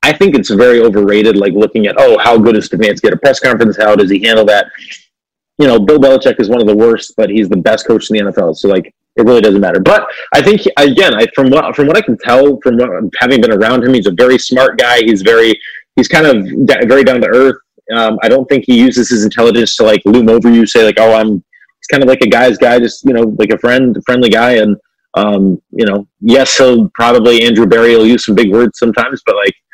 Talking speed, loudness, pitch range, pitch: 255 wpm, -8 LUFS, 110-125 Hz, 115 Hz